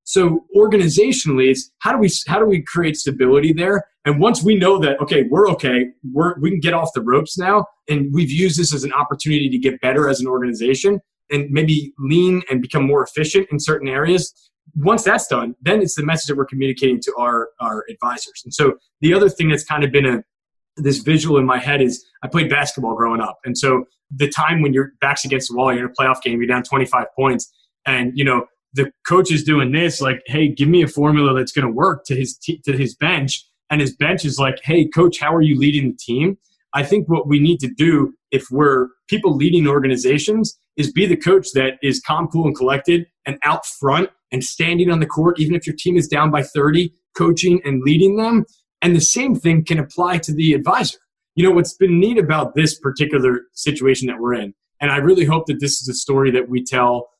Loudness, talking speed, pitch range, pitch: -17 LUFS, 230 wpm, 135-175 Hz, 150 Hz